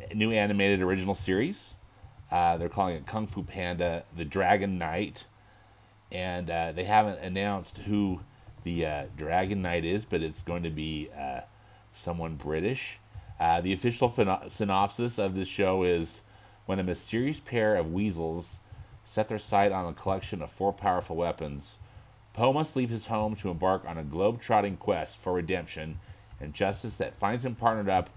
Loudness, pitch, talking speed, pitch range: -30 LUFS, 100 Hz, 165 wpm, 90-105 Hz